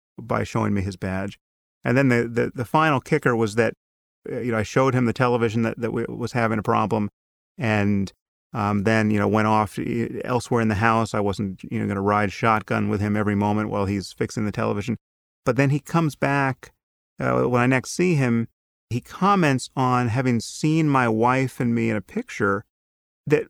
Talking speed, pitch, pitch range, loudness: 205 wpm, 115 Hz, 105-125 Hz, -23 LUFS